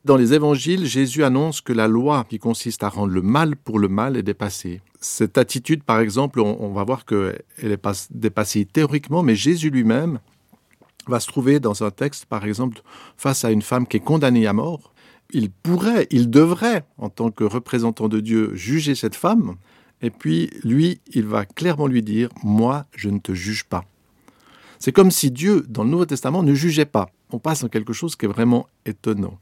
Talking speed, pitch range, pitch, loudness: 200 wpm, 105-145 Hz, 120 Hz, -20 LUFS